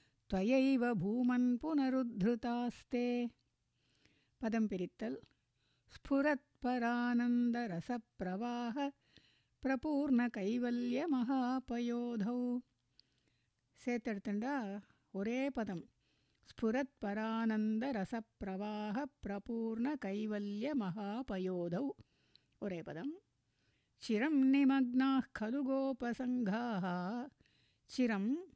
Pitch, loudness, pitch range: 240 Hz, -37 LUFS, 210-260 Hz